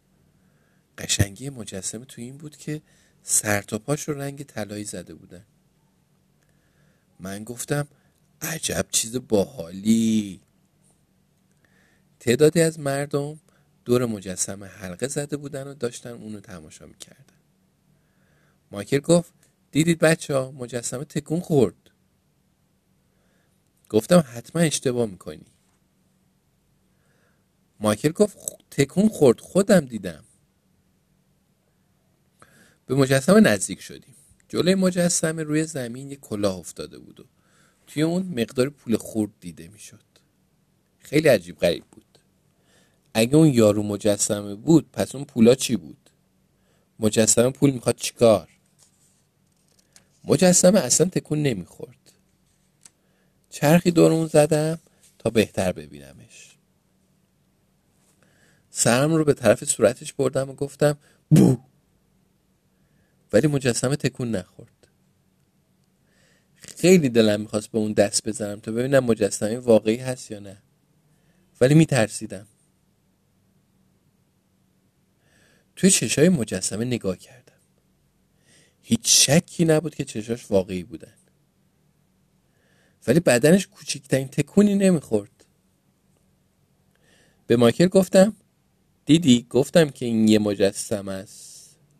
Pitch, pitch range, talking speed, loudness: 130 Hz, 110-155 Hz, 100 wpm, -21 LUFS